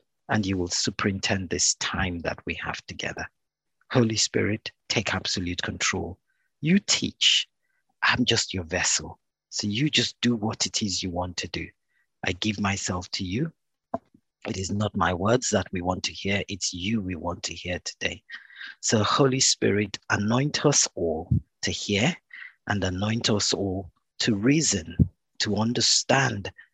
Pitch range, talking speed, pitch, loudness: 90-115 Hz, 155 wpm, 100 Hz, -25 LUFS